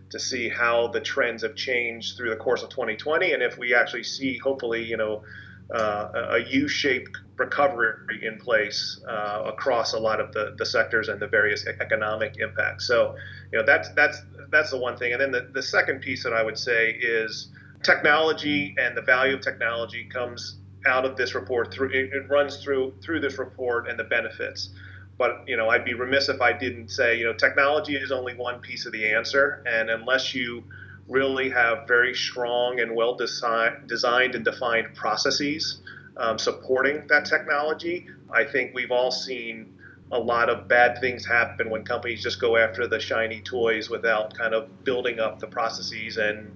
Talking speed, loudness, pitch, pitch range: 190 wpm, -24 LUFS, 125 Hz, 115-145 Hz